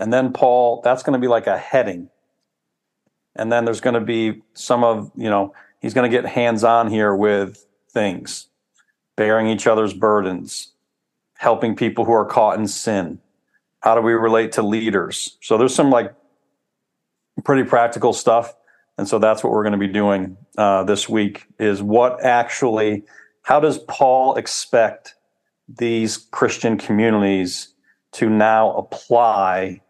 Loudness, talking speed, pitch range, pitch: -18 LUFS, 155 wpm, 105-115 Hz, 110 Hz